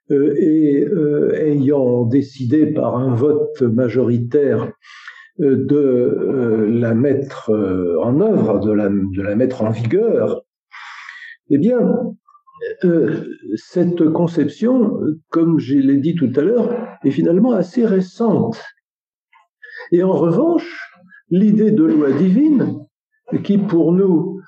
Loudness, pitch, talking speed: -16 LUFS, 165 Hz, 120 wpm